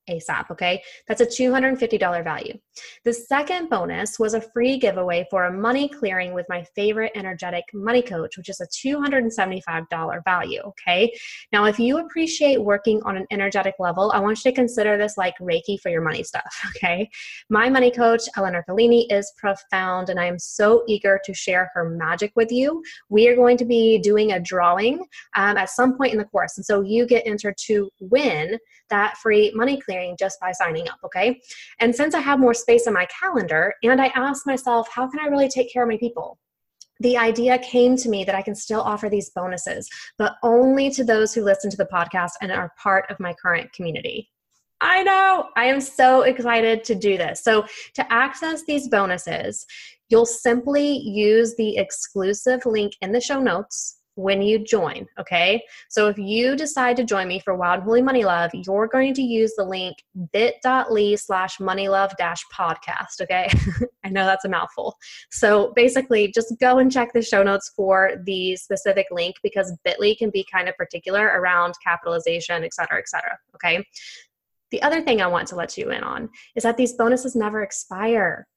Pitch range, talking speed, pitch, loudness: 190-245 Hz, 190 wpm, 210 Hz, -21 LUFS